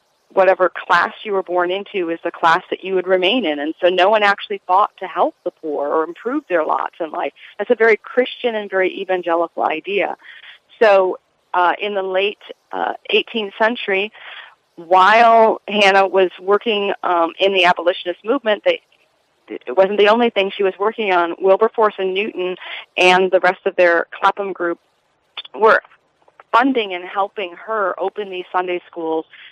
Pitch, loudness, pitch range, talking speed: 190 Hz, -17 LUFS, 180-210 Hz, 170 wpm